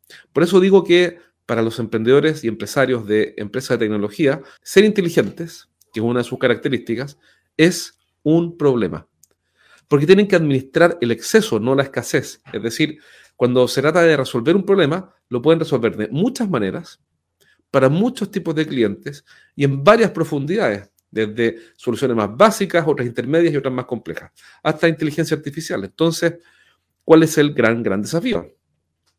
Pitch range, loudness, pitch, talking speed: 115-170 Hz, -18 LUFS, 140 Hz, 160 wpm